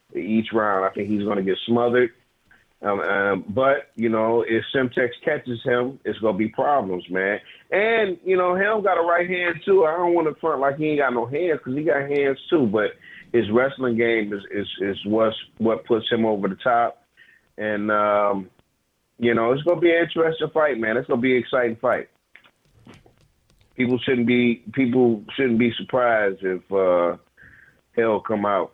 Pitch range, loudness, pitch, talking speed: 105-145 Hz, -22 LUFS, 120 Hz, 195 wpm